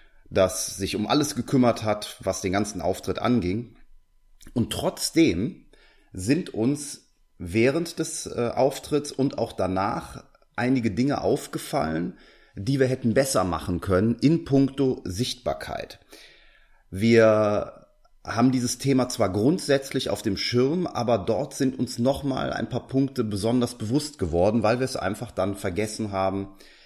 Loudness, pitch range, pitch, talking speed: -25 LUFS, 100-135 Hz, 115 Hz, 135 wpm